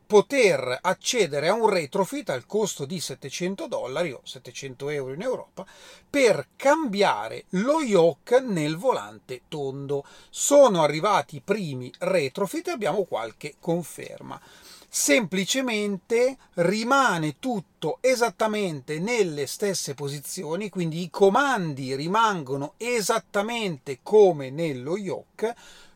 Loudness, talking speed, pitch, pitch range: -24 LUFS, 105 wpm, 190 Hz, 150-225 Hz